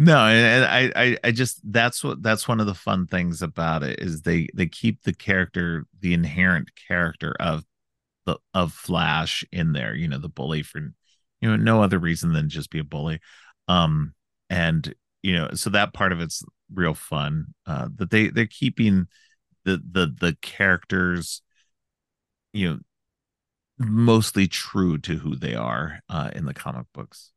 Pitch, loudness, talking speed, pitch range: 95 Hz, -23 LUFS, 175 wpm, 85-115 Hz